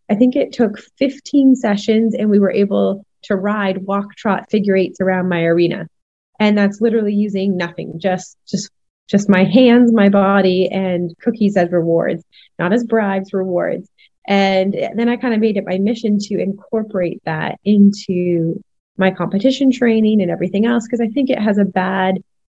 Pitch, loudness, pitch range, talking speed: 200 Hz, -16 LUFS, 185-225 Hz, 175 wpm